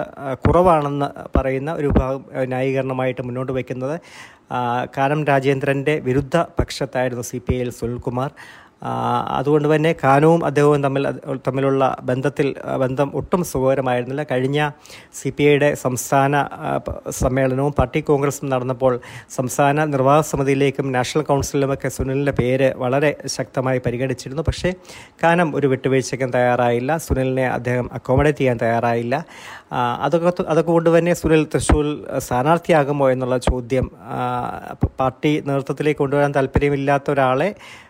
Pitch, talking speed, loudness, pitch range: 135 Hz, 105 wpm, -19 LUFS, 130-145 Hz